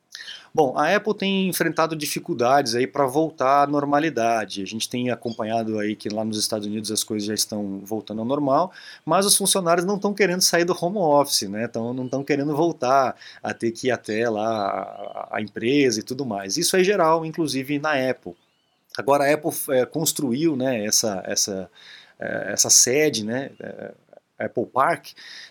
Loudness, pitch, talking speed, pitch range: -22 LUFS, 130 Hz, 180 wpm, 110-160 Hz